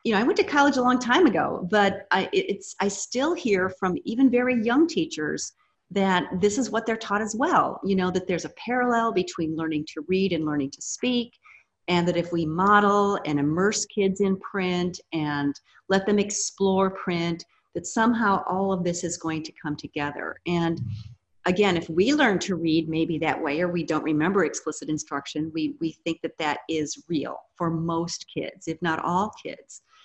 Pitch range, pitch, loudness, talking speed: 160-210 Hz, 185 Hz, -25 LUFS, 195 wpm